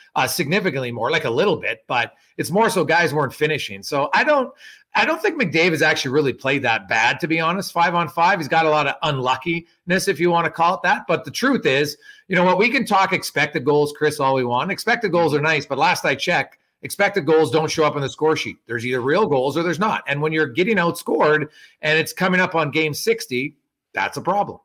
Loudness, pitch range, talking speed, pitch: -19 LUFS, 150-185 Hz, 245 wpm, 160 Hz